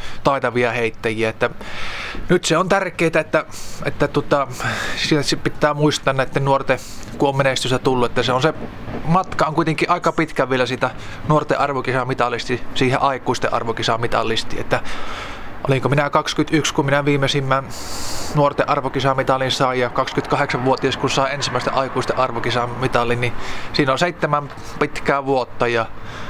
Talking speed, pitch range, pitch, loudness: 130 wpm, 120-145 Hz, 135 Hz, -19 LUFS